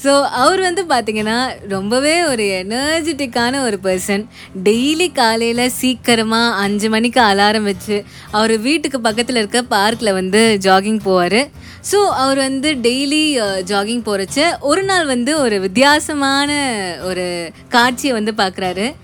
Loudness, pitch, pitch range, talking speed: -15 LUFS, 235 Hz, 205-275 Hz, 125 wpm